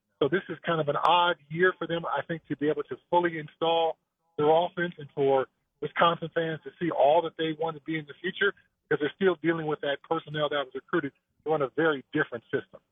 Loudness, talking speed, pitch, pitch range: -28 LUFS, 230 wpm, 160 Hz, 150-170 Hz